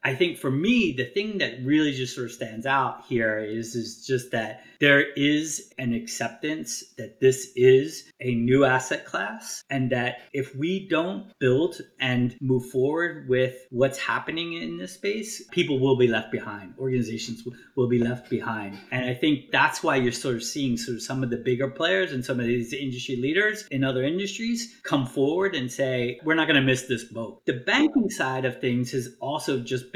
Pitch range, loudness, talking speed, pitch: 125-145 Hz, -25 LUFS, 195 wpm, 130 Hz